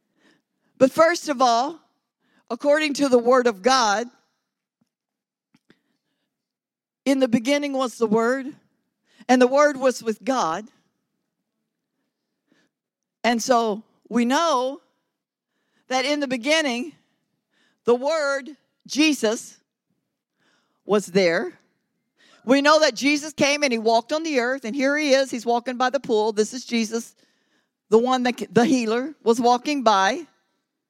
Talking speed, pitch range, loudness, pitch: 130 wpm, 230-285 Hz, -21 LUFS, 255 Hz